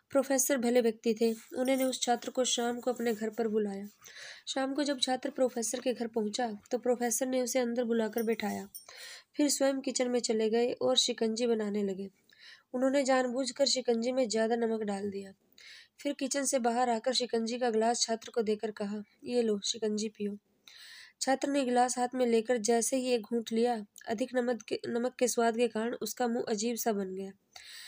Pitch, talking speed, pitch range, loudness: 240 Hz, 190 wpm, 225-255 Hz, -31 LUFS